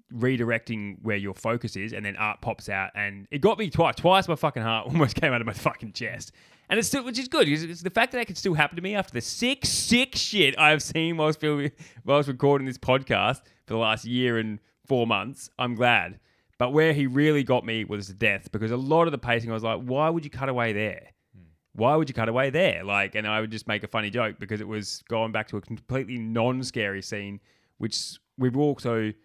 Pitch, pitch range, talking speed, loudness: 120 Hz, 110-150 Hz, 240 wpm, -25 LUFS